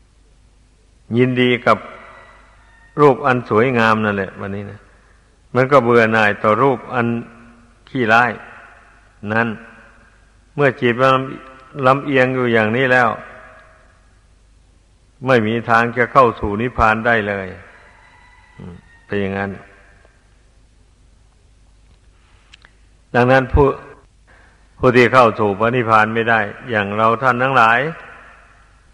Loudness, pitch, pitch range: -15 LUFS, 110 Hz, 100-125 Hz